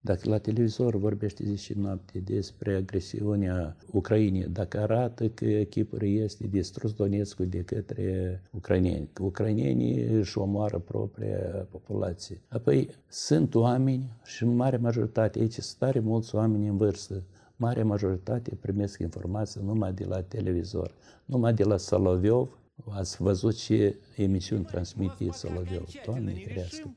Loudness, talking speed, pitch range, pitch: -29 LUFS, 130 wpm, 95-110 Hz, 105 Hz